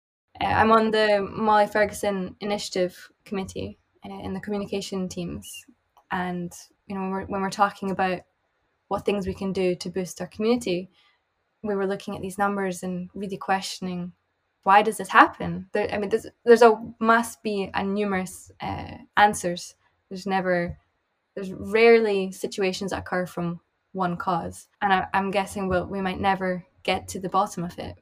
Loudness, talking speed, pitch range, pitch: -24 LUFS, 170 wpm, 185-205 Hz, 195 Hz